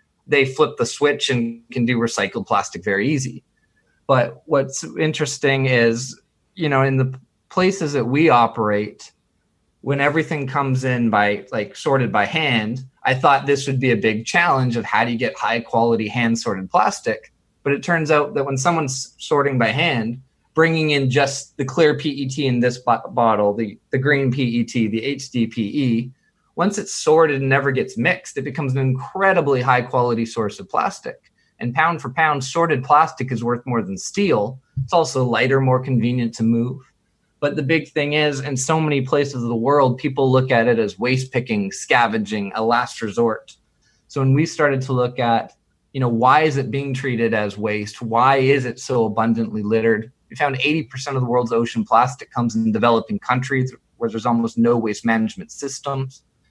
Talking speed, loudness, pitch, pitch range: 185 wpm, -19 LUFS, 130 Hz, 115-145 Hz